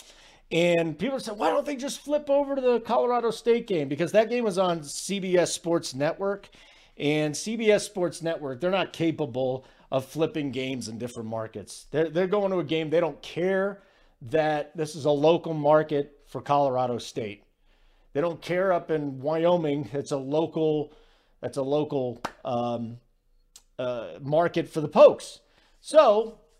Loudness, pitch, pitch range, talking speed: -26 LUFS, 160 Hz, 145-195 Hz, 160 wpm